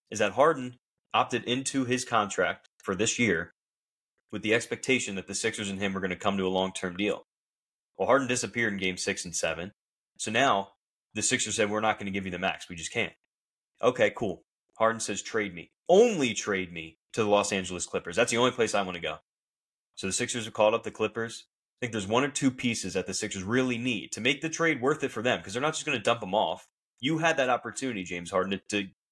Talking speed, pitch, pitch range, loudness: 245 wpm, 110 Hz, 95-125 Hz, -28 LUFS